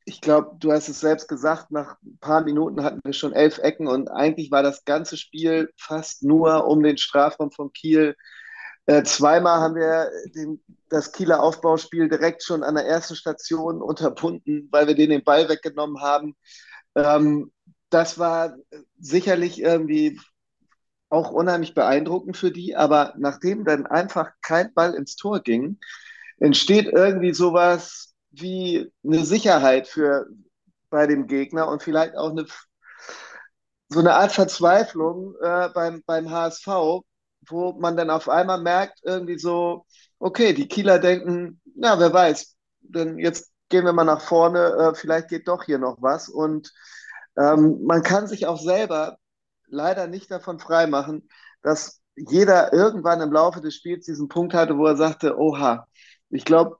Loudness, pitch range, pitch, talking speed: -21 LUFS, 150-175 Hz, 160 Hz, 155 wpm